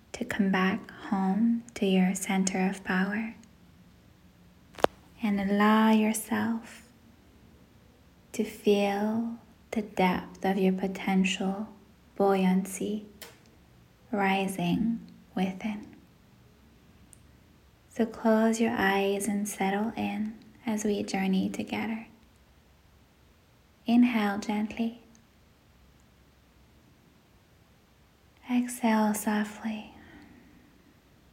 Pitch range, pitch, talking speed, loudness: 195-220 Hz, 210 Hz, 70 wpm, -29 LUFS